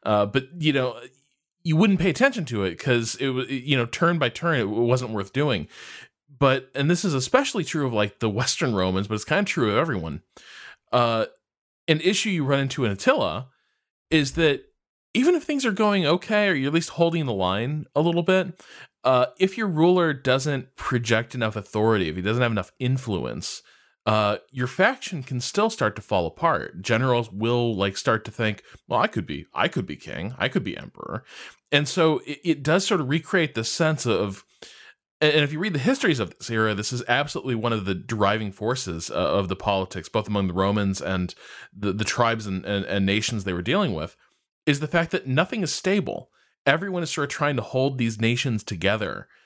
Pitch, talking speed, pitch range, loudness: 130 Hz, 205 wpm, 110-165 Hz, -24 LUFS